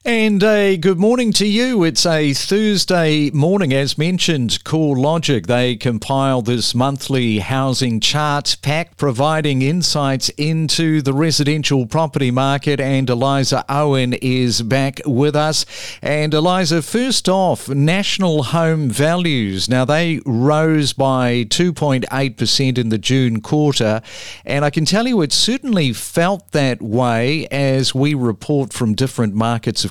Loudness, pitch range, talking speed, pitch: -16 LUFS, 130-160 Hz, 140 wpm, 140 Hz